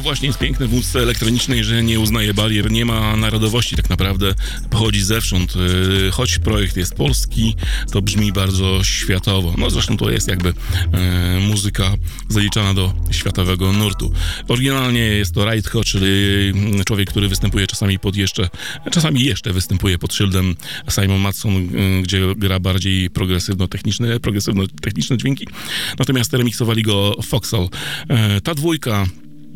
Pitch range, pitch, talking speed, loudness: 95-115 Hz, 100 Hz, 140 wpm, -17 LUFS